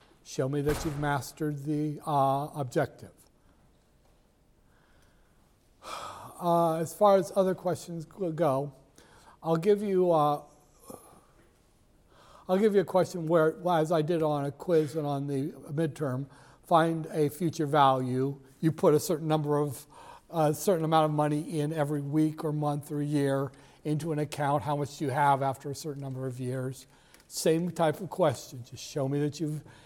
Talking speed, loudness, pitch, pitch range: 165 wpm, -29 LUFS, 150 Hz, 140-165 Hz